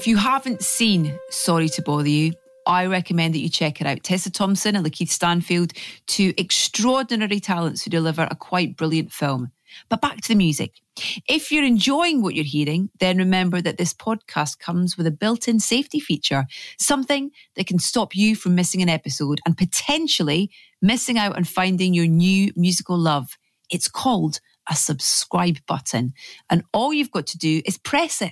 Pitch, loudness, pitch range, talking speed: 180 Hz, -21 LUFS, 165-220 Hz, 180 wpm